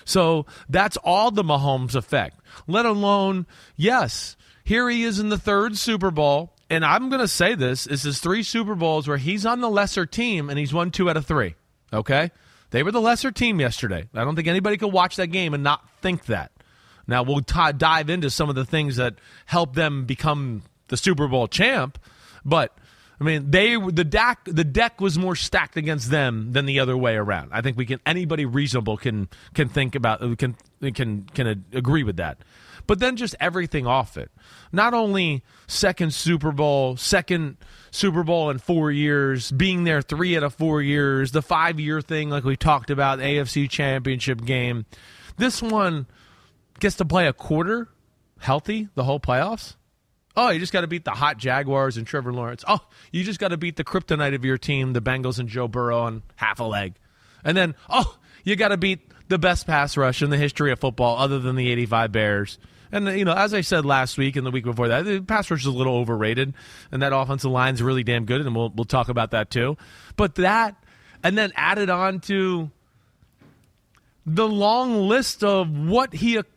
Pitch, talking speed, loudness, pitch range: 145 Hz, 205 wpm, -22 LUFS, 130-185 Hz